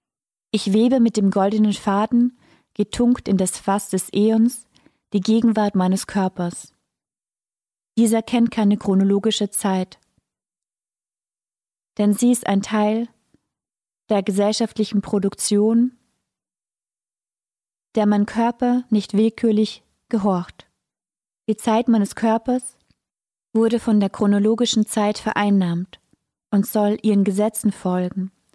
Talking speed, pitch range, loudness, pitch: 105 wpm, 200-225 Hz, -19 LUFS, 210 Hz